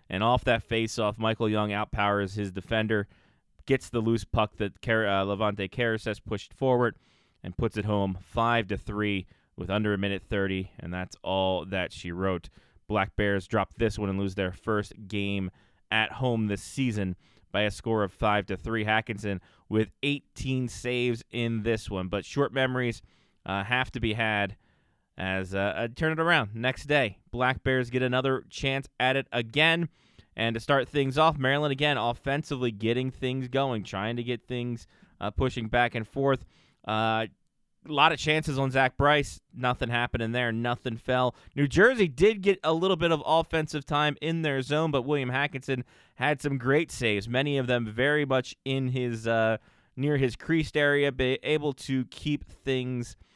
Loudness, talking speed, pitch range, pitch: -28 LUFS, 180 wpm, 105-135 Hz, 120 Hz